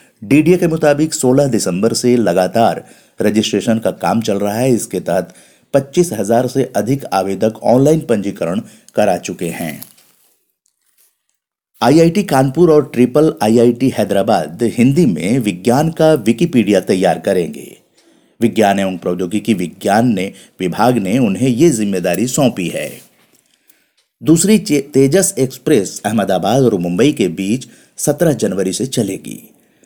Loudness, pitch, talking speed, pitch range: -14 LUFS, 120 Hz, 125 wpm, 105-145 Hz